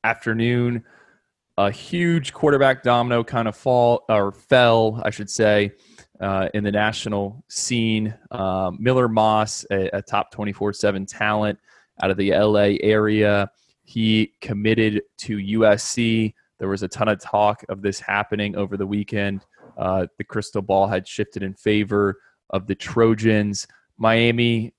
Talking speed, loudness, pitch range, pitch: 145 wpm, -21 LUFS, 100-115 Hz, 105 Hz